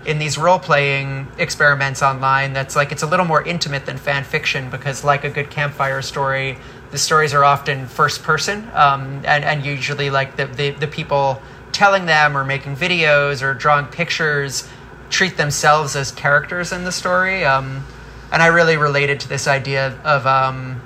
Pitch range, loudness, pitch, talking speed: 135-155 Hz, -17 LUFS, 140 Hz, 180 wpm